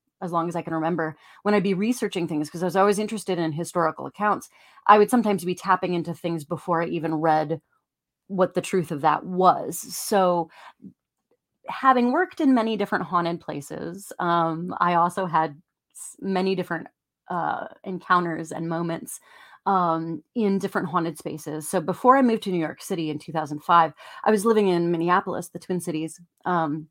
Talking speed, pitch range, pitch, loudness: 175 wpm, 165-195 Hz, 175 Hz, -24 LUFS